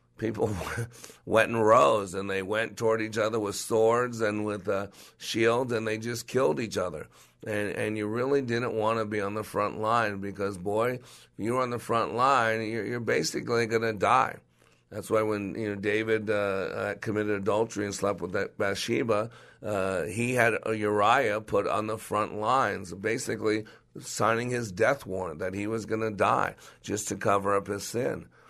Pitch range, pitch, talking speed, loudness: 105-115 Hz, 110 Hz, 175 wpm, -28 LUFS